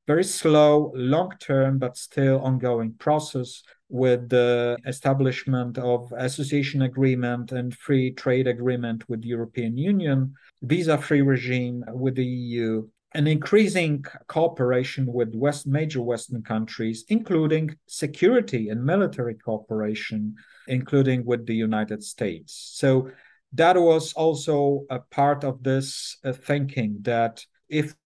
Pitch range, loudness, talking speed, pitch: 120-145 Hz, -24 LUFS, 120 wpm, 130 Hz